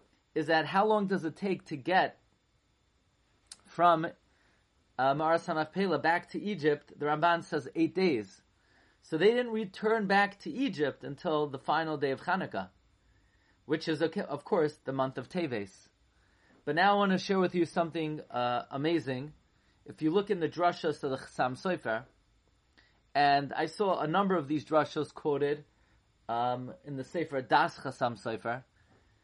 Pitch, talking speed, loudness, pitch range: 155 Hz, 160 wpm, -31 LUFS, 130-175 Hz